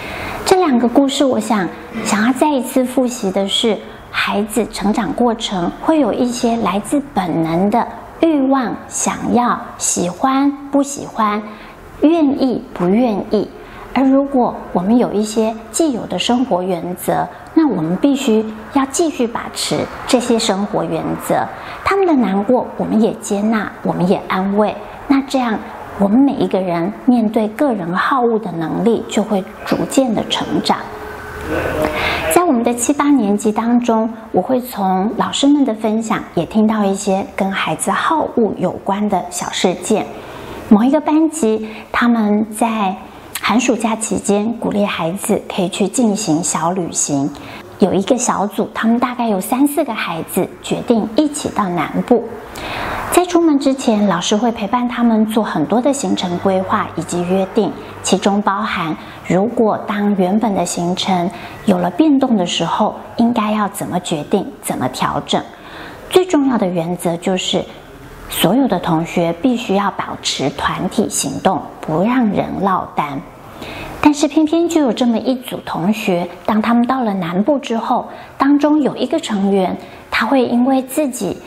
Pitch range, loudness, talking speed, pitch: 195-260 Hz, -16 LUFS, 230 characters per minute, 225 Hz